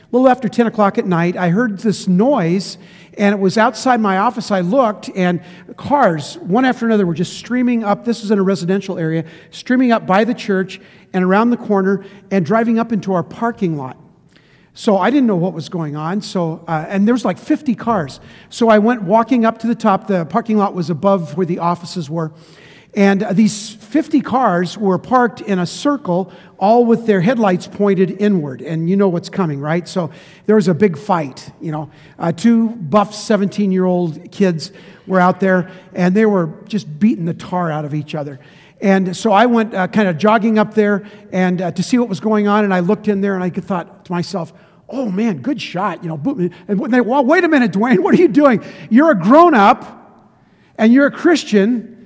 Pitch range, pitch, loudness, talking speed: 180-220 Hz, 195 Hz, -16 LUFS, 210 wpm